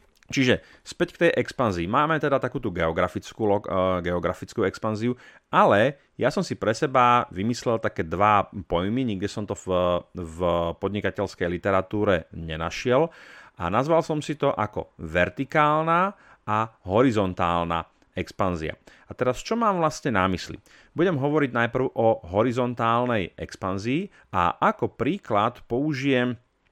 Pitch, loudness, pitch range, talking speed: 110 Hz, -24 LUFS, 90-130 Hz, 125 wpm